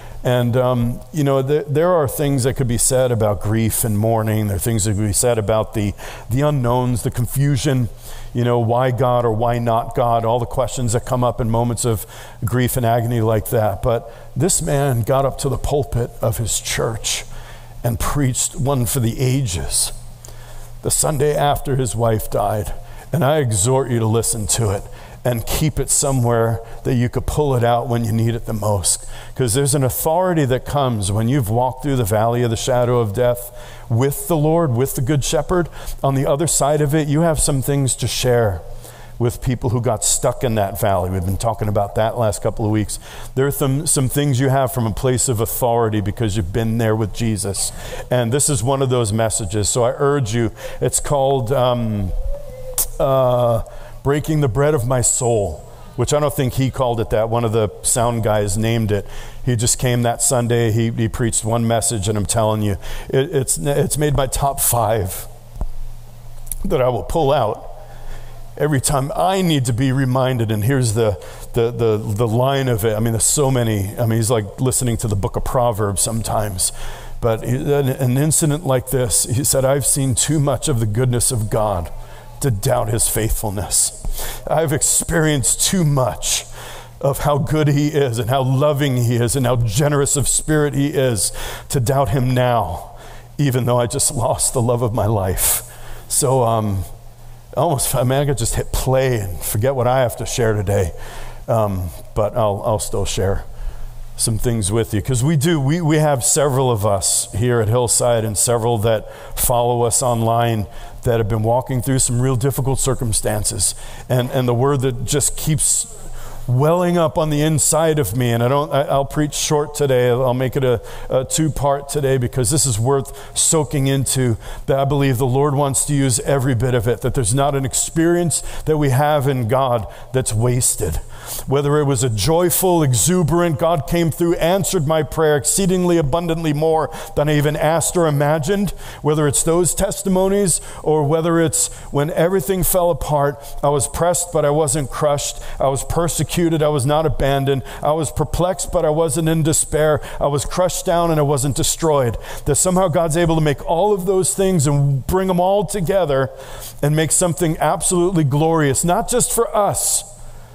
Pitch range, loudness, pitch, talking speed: 115-145 Hz, -18 LUFS, 125 Hz, 195 wpm